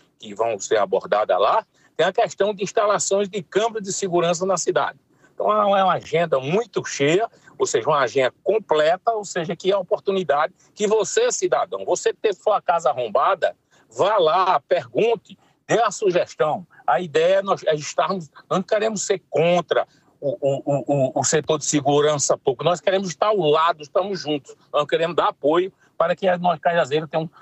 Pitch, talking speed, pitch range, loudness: 185 Hz, 175 wpm, 160-210 Hz, -21 LUFS